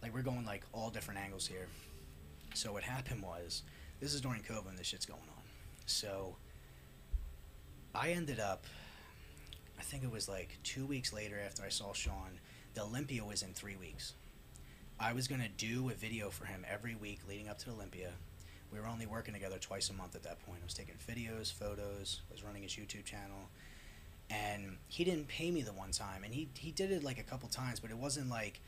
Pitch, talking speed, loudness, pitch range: 100 Hz, 210 wpm, -43 LUFS, 85-115 Hz